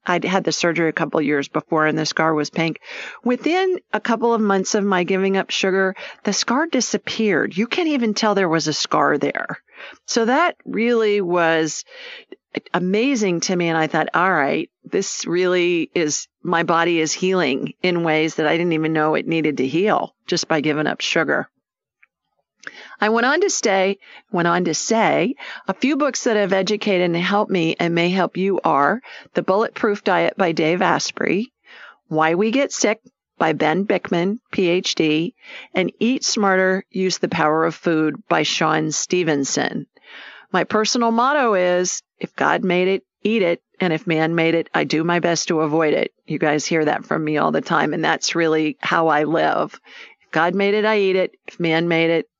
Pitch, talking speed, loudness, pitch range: 180 Hz, 190 wpm, -19 LUFS, 160-210 Hz